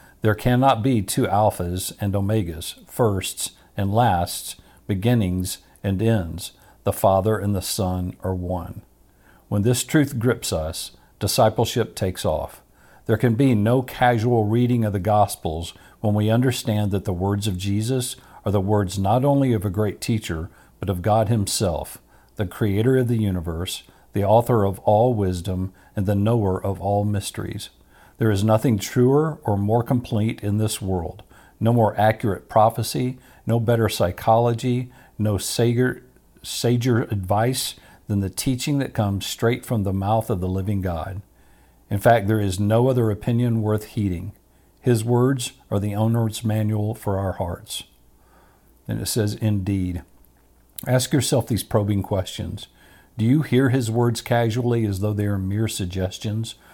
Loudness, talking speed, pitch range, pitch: -22 LUFS, 155 wpm, 95-120 Hz, 105 Hz